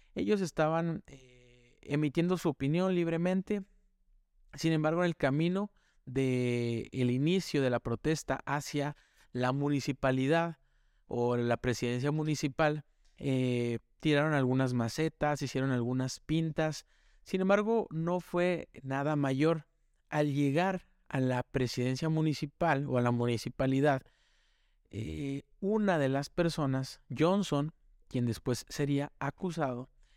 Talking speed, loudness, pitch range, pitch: 115 wpm, -32 LUFS, 130-165 Hz, 145 Hz